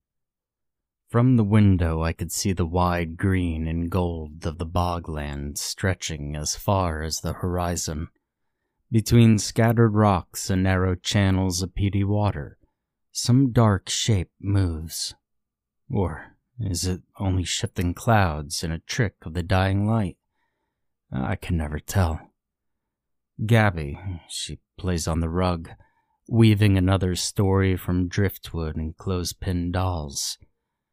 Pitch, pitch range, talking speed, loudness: 90 Hz, 85-100 Hz, 125 wpm, -24 LUFS